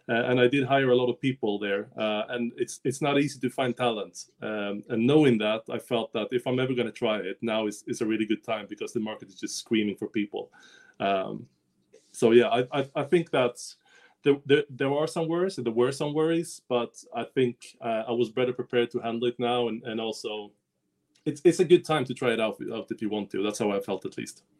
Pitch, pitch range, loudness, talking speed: 120 Hz, 110-135 Hz, -27 LUFS, 250 wpm